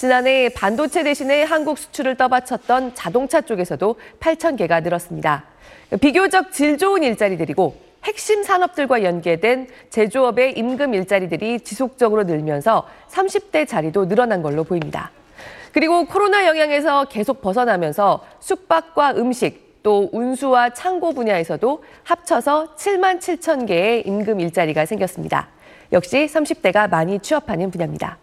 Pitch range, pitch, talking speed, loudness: 200-315 Hz, 250 Hz, 315 characters per minute, -19 LUFS